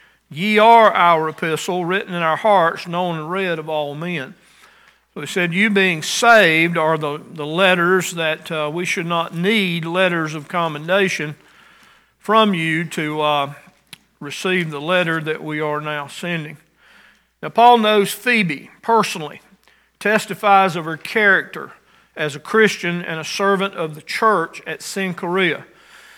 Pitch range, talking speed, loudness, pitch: 155-195 Hz, 150 wpm, -17 LUFS, 175 Hz